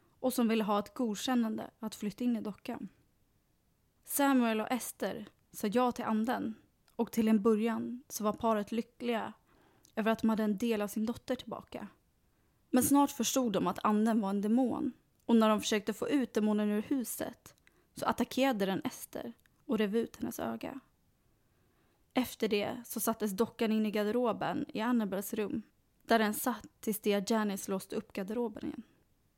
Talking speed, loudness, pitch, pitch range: 170 wpm, -33 LUFS, 225 Hz, 215-245 Hz